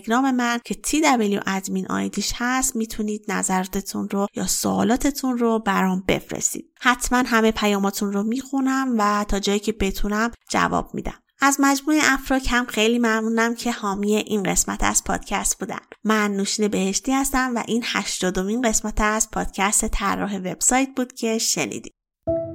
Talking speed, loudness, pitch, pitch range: 145 wpm, -21 LUFS, 220 Hz, 200-250 Hz